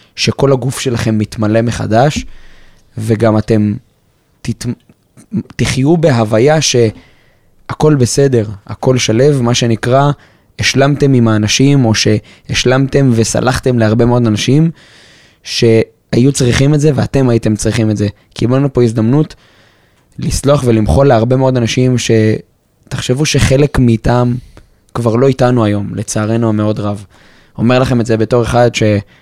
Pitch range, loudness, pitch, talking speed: 110-130 Hz, -12 LUFS, 120 Hz, 120 wpm